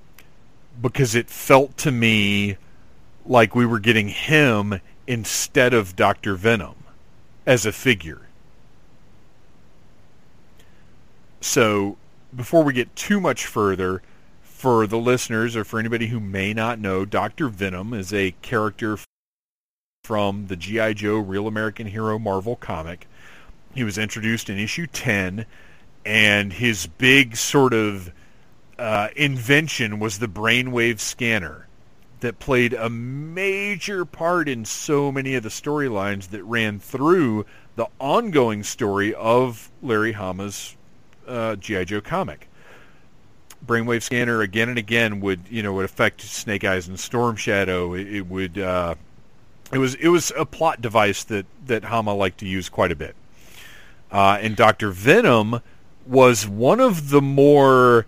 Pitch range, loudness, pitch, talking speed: 100-125 Hz, -20 LUFS, 110 Hz, 135 wpm